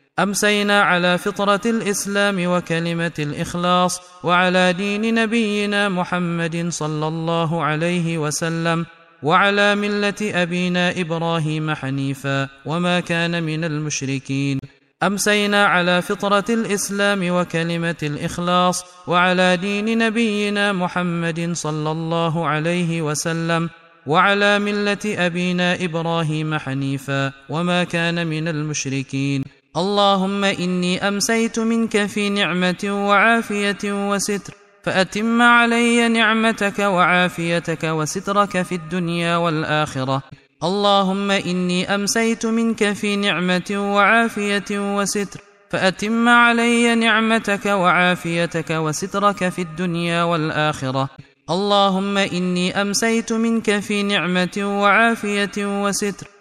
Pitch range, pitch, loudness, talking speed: 165-205 Hz, 180 Hz, -19 LUFS, 90 wpm